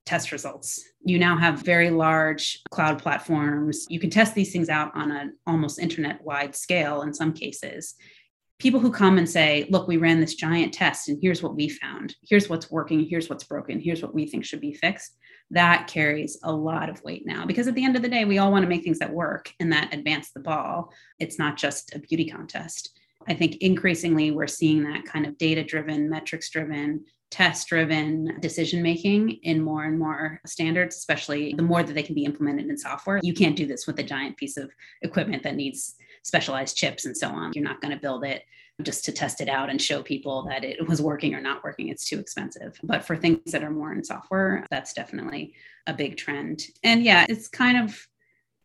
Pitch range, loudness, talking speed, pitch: 150-175 Hz, -24 LUFS, 215 wpm, 160 Hz